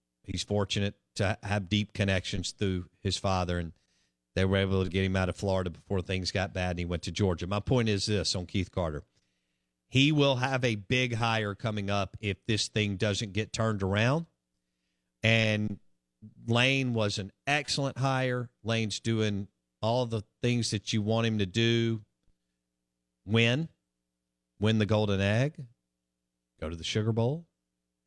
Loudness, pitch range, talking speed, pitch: -29 LUFS, 90-115 Hz, 165 wpm, 100 Hz